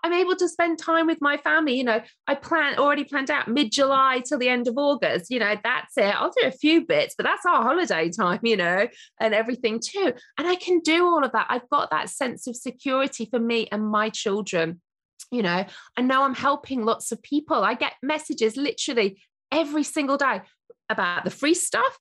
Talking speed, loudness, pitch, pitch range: 215 wpm, -23 LUFS, 270 Hz, 230-315 Hz